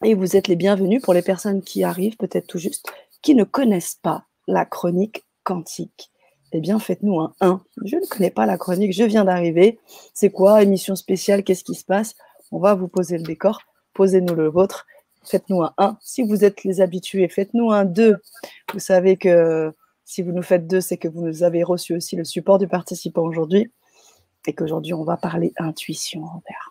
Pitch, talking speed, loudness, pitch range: 190 Hz, 200 wpm, -20 LUFS, 175-200 Hz